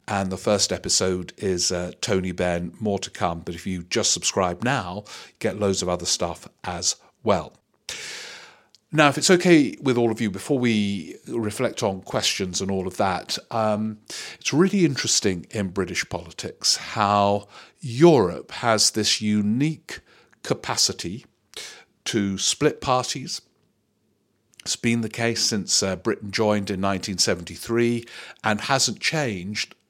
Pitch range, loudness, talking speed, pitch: 95-120 Hz, -23 LUFS, 140 wpm, 105 Hz